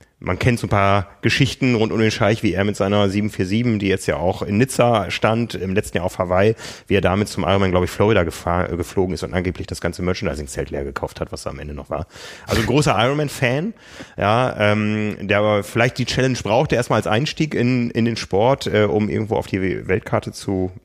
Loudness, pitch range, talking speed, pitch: -19 LUFS, 95-115 Hz, 220 wpm, 105 Hz